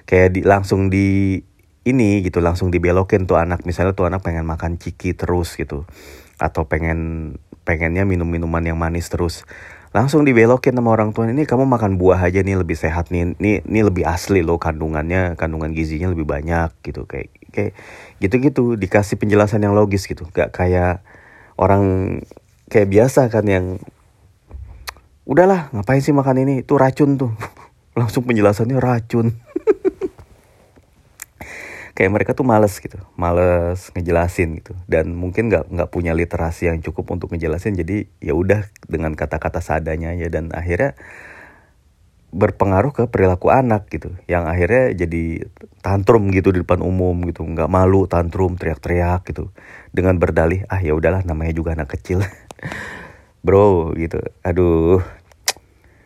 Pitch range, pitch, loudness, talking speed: 85-105 Hz, 90 Hz, -18 LUFS, 145 wpm